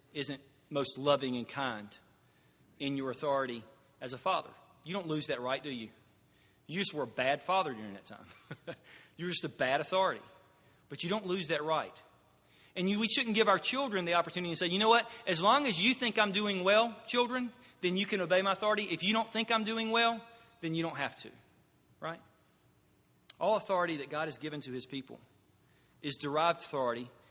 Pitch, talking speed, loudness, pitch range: 165 Hz, 200 wpm, -32 LUFS, 135-210 Hz